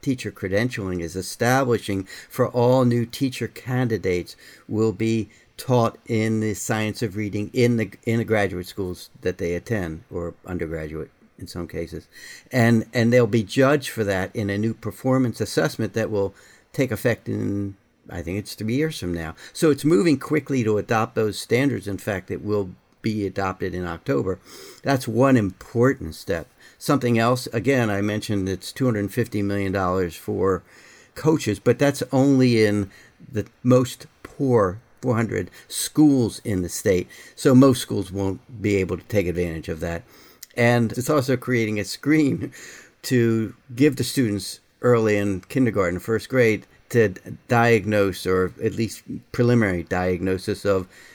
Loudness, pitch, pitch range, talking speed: -23 LUFS, 110 Hz, 95-125 Hz, 155 wpm